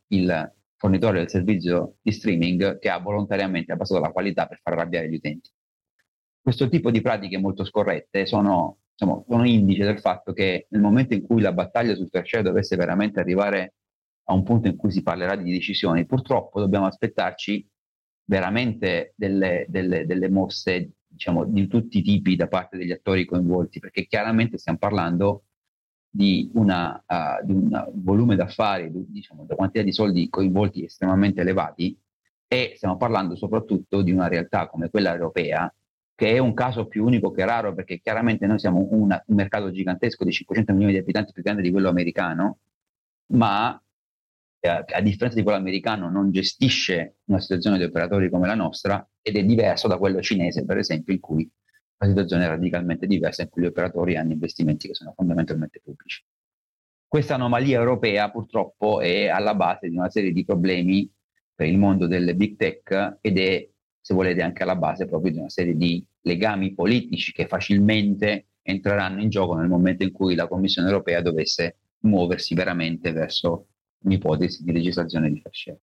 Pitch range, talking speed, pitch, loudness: 90-105 Hz, 170 wpm, 95 Hz, -23 LUFS